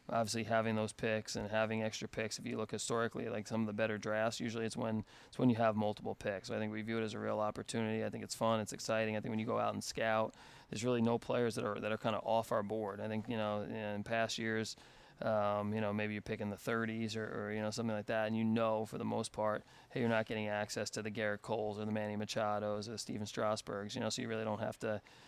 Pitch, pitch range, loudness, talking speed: 110 Hz, 105-115 Hz, -38 LUFS, 280 wpm